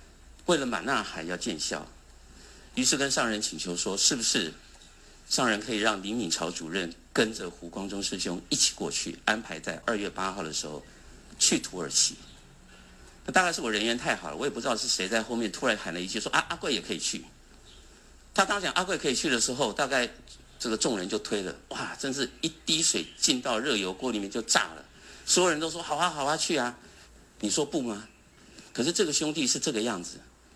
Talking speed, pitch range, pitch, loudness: 295 characters per minute, 80-125 Hz, 100 Hz, -28 LUFS